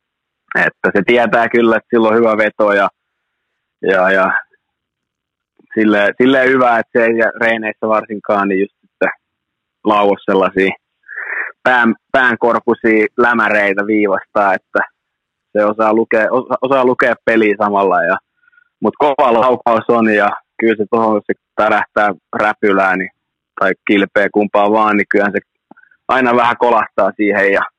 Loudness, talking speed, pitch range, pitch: -13 LUFS, 125 wpm, 105-115 Hz, 110 Hz